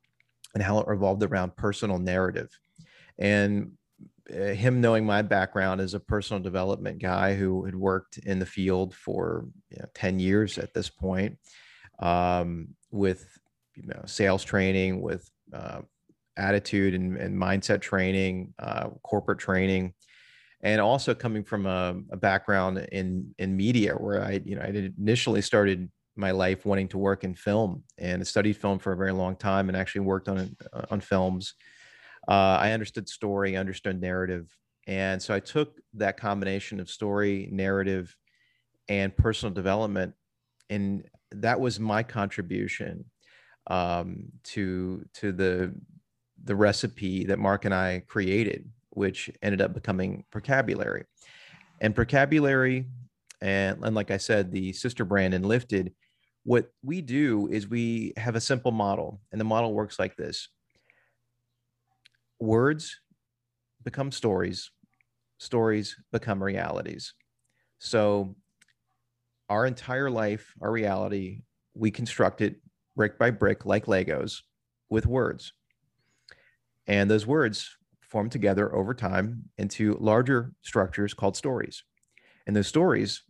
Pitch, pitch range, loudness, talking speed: 100 Hz, 95-110 Hz, -28 LUFS, 135 wpm